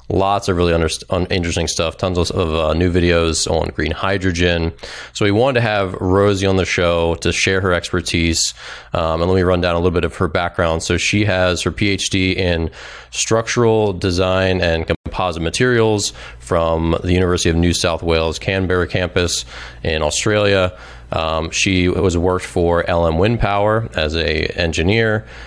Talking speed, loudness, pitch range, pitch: 170 wpm, -17 LUFS, 85-95 Hz, 90 Hz